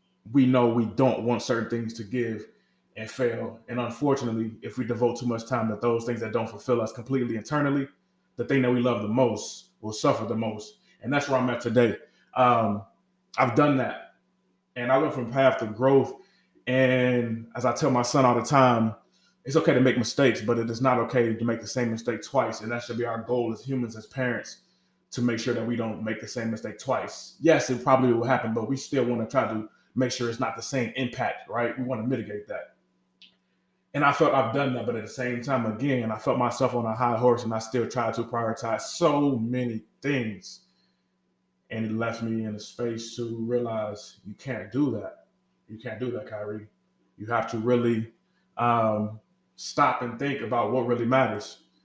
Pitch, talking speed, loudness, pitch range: 120 Hz, 215 wpm, -26 LUFS, 115-130 Hz